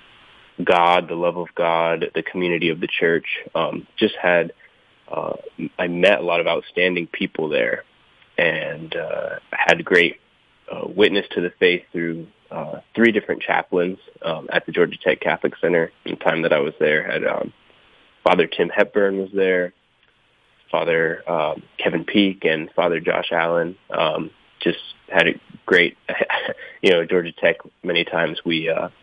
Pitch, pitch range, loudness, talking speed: 85 Hz, 85-90 Hz, -20 LUFS, 165 wpm